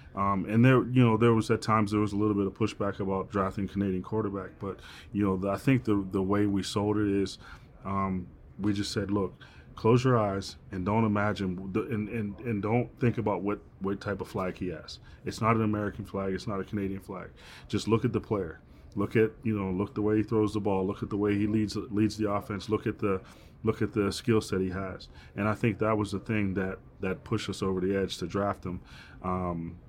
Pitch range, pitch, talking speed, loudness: 95-110 Hz, 100 Hz, 245 wpm, -30 LUFS